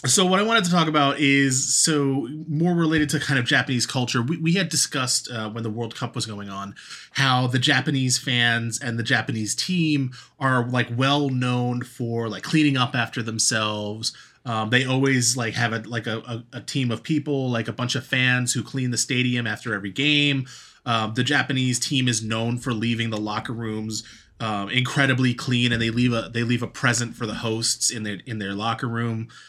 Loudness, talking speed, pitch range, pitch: -22 LUFS, 210 wpm, 115-135 Hz, 125 Hz